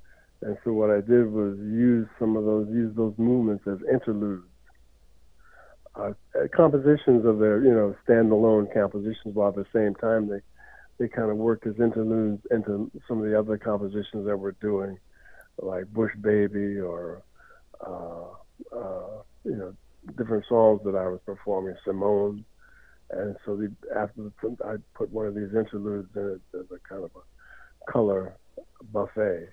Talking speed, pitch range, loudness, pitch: 160 wpm, 100-110 Hz, -26 LUFS, 105 Hz